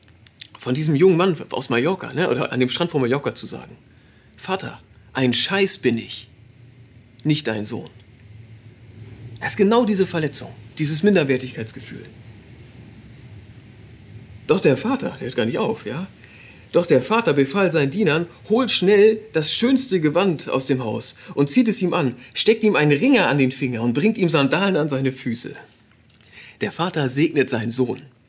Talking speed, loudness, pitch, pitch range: 160 wpm, -20 LUFS, 130 Hz, 115-175 Hz